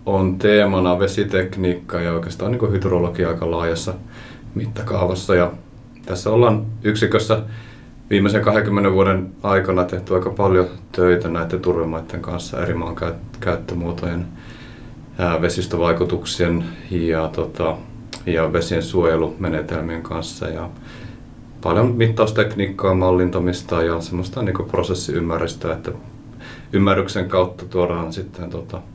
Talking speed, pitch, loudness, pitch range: 100 wpm, 95 Hz, -20 LUFS, 85-110 Hz